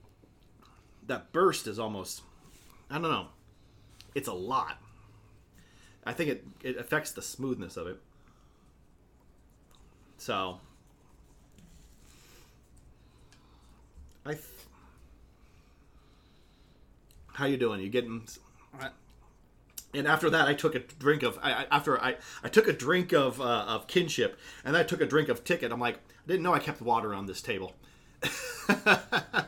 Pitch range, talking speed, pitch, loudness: 85-140 Hz, 130 wpm, 110 Hz, -30 LUFS